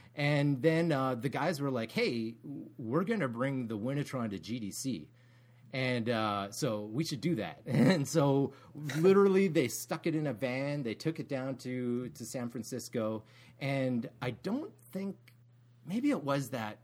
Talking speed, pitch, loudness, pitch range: 170 wpm, 130 Hz, -33 LUFS, 120-150 Hz